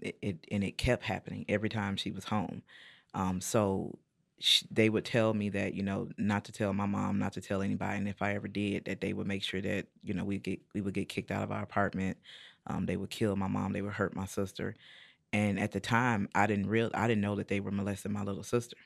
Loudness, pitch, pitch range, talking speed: -33 LUFS, 100 Hz, 95-105 Hz, 255 wpm